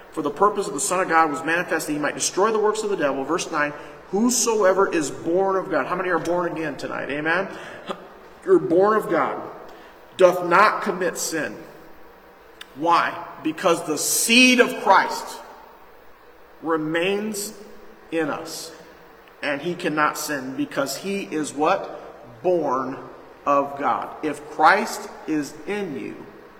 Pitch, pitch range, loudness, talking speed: 180 Hz, 160-210 Hz, -21 LUFS, 150 wpm